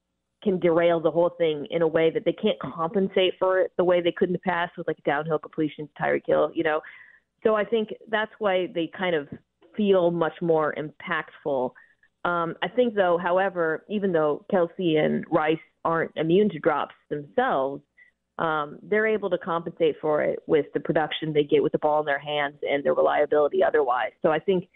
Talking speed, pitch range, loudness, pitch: 195 wpm, 155-190 Hz, -25 LUFS, 170 Hz